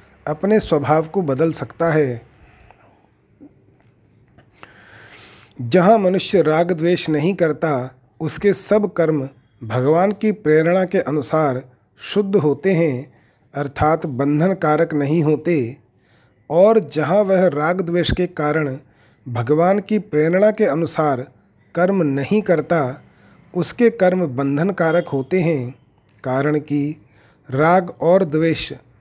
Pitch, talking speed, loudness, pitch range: 155 Hz, 110 wpm, -18 LUFS, 135-180 Hz